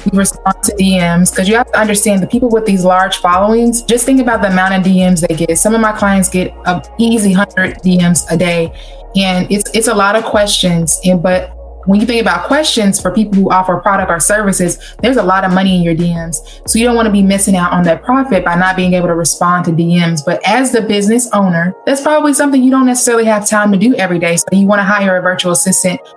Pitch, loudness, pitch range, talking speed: 195 Hz, -11 LUFS, 180-220 Hz, 250 wpm